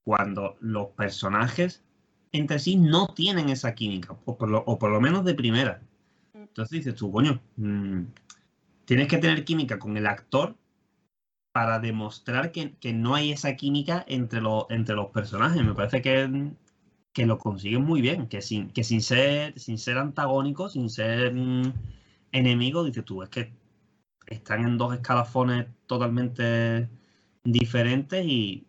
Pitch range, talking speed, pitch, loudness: 110-140 Hz, 150 wpm, 120 Hz, -26 LUFS